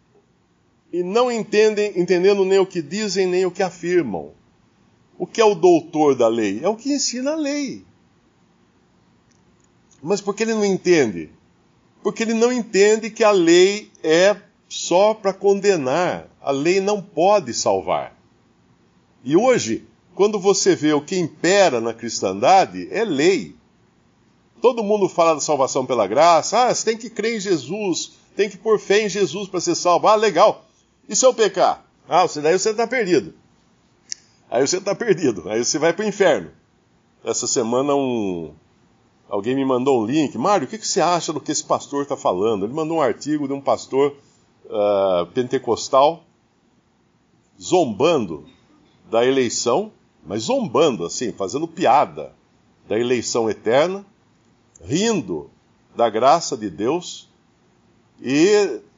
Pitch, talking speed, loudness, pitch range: 195 Hz, 150 wpm, -19 LUFS, 155-215 Hz